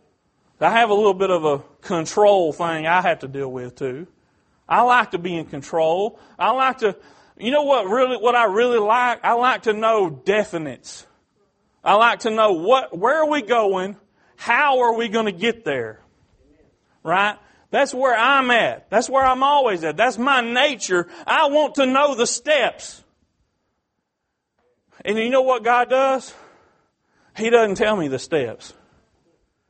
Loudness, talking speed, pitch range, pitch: -19 LUFS, 170 wpm, 190-260 Hz, 230 Hz